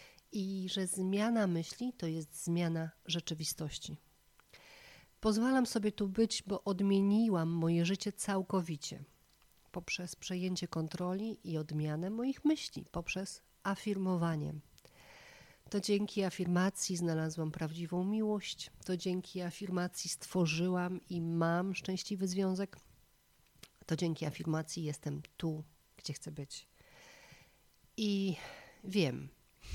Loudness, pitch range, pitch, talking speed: -36 LUFS, 165-195 Hz, 180 Hz, 100 wpm